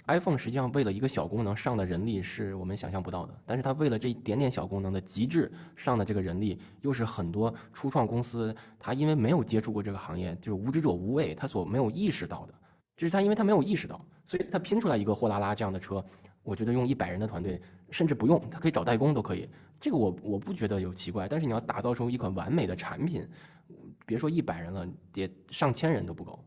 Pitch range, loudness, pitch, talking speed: 95-140 Hz, -31 LUFS, 110 Hz, 385 characters per minute